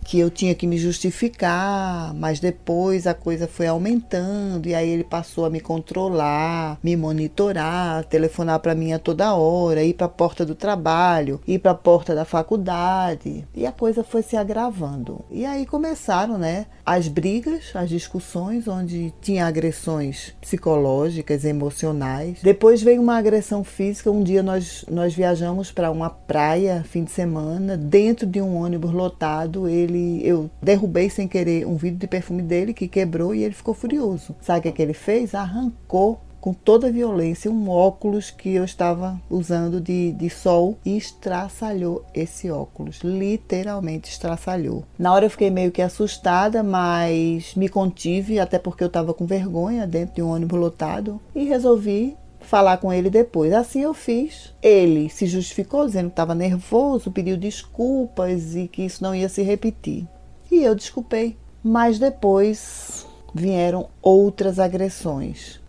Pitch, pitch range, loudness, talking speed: 180 Hz, 170-205 Hz, -21 LUFS, 160 wpm